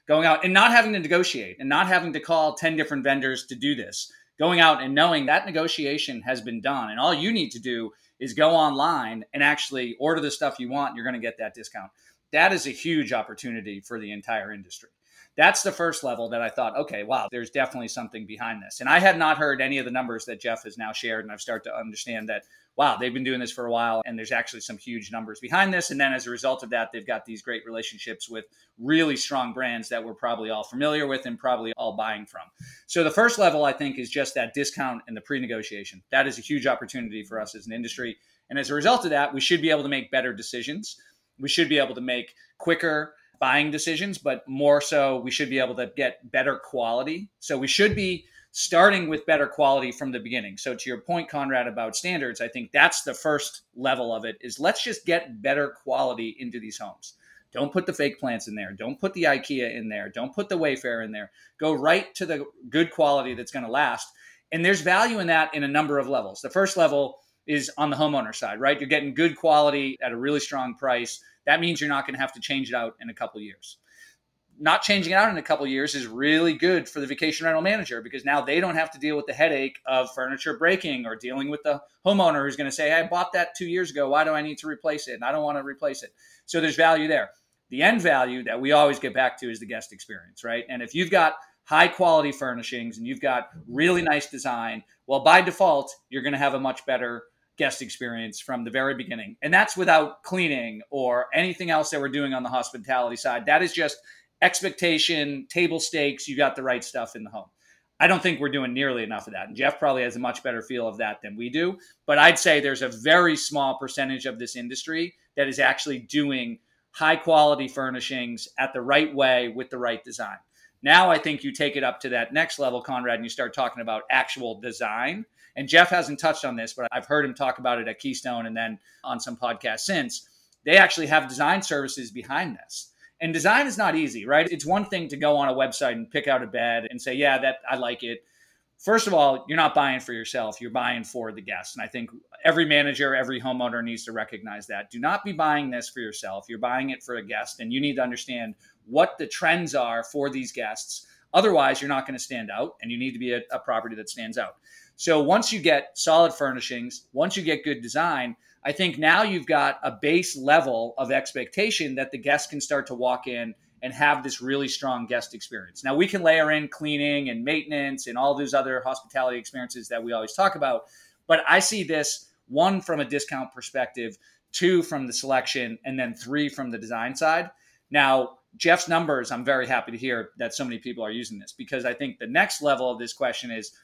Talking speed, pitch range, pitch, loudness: 235 wpm, 125-160 Hz, 140 Hz, -24 LUFS